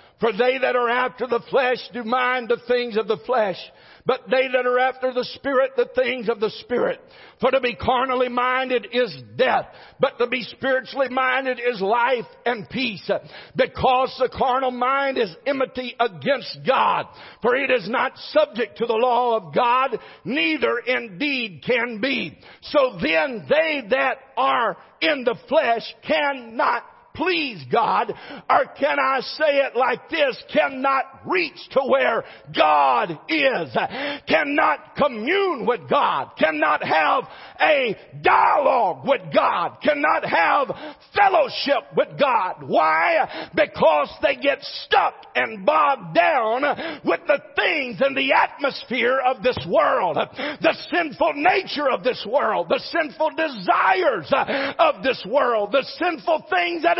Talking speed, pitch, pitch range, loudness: 145 wpm, 260 Hz, 245-305 Hz, -21 LUFS